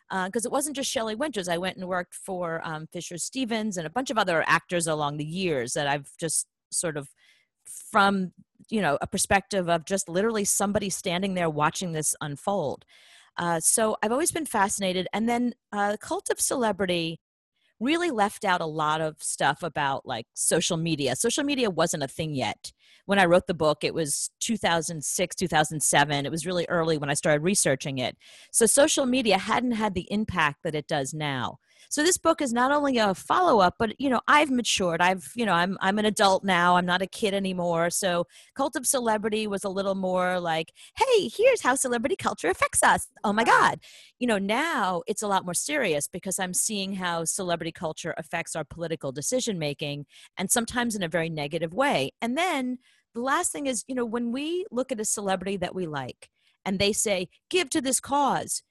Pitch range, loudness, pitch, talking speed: 165-230 Hz, -26 LUFS, 190 Hz, 200 wpm